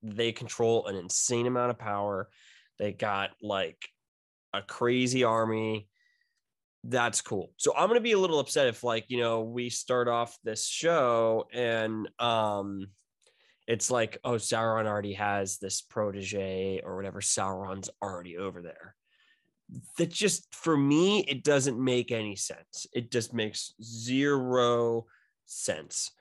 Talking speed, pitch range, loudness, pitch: 140 wpm, 100-125 Hz, -29 LUFS, 115 Hz